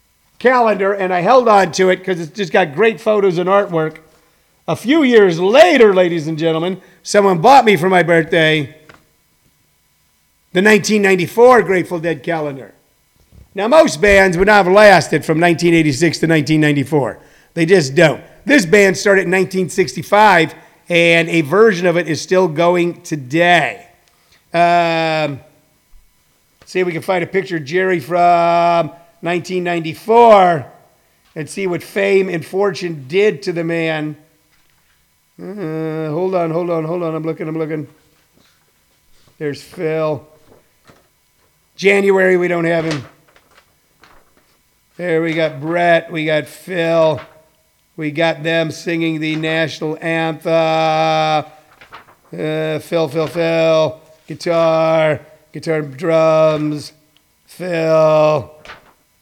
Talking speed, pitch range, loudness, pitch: 125 wpm, 155-185 Hz, -14 LUFS, 165 Hz